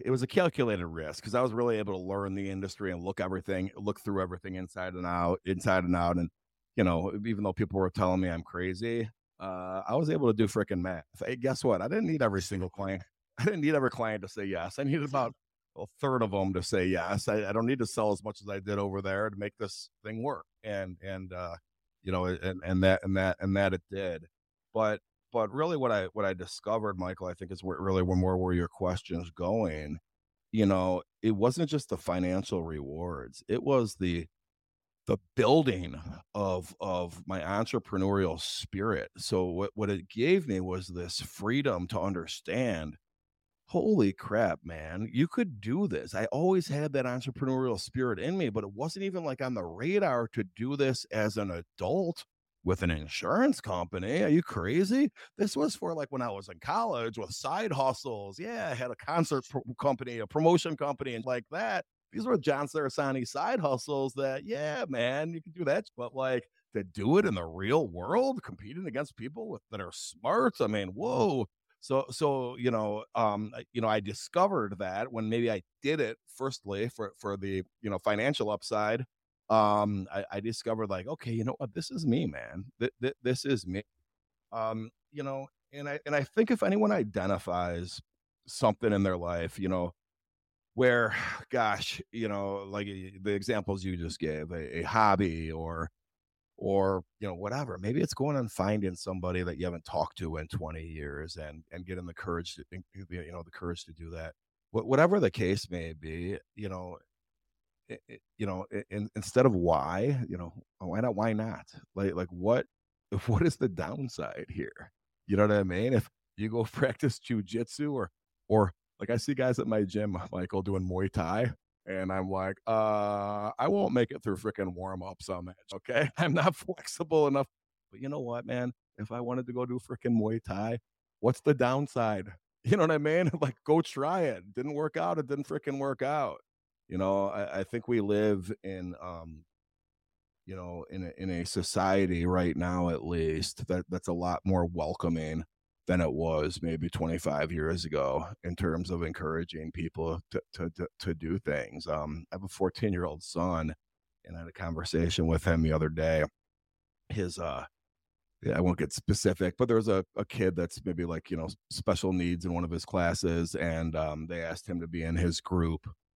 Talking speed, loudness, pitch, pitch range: 195 wpm, -32 LUFS, 95 Hz, 90-120 Hz